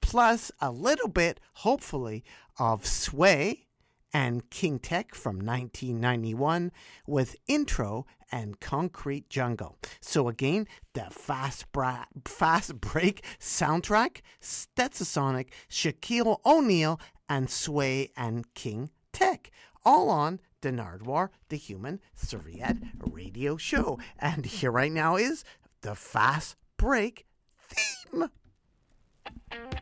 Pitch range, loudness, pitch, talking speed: 125-185 Hz, -29 LUFS, 145 Hz, 105 wpm